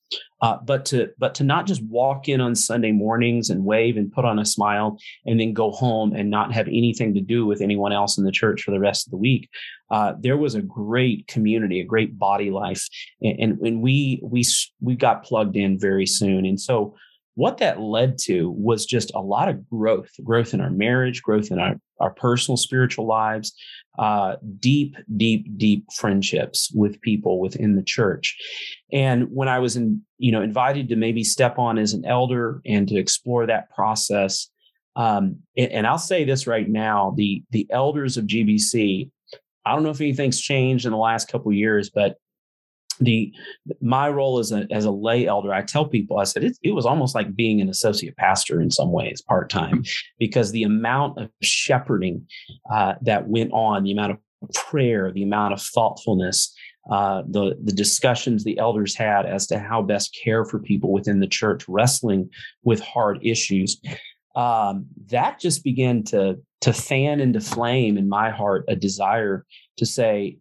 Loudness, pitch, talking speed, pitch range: -21 LUFS, 110 Hz, 190 wpm, 105-125 Hz